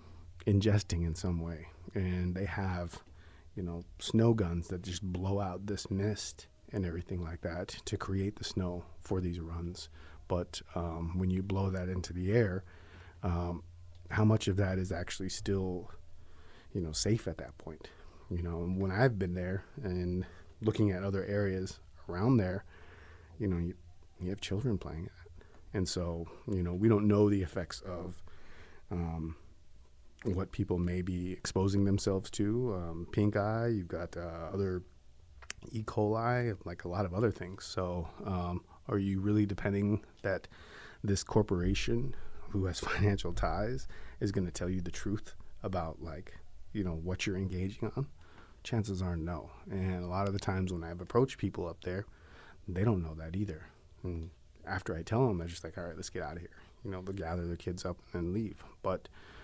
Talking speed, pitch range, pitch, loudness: 180 wpm, 85-100 Hz, 90 Hz, -35 LUFS